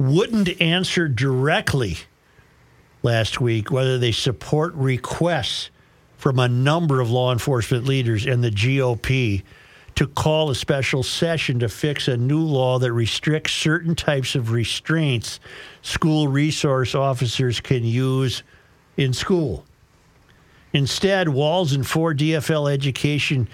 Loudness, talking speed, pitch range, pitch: -21 LUFS, 120 wpm, 125-155 Hz, 135 Hz